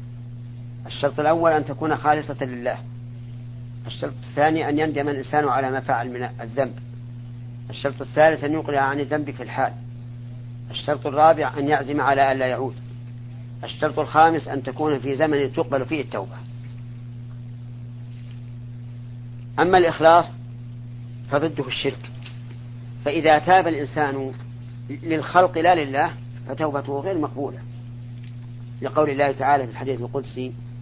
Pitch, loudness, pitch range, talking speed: 125 Hz, -22 LUFS, 120-145 Hz, 115 wpm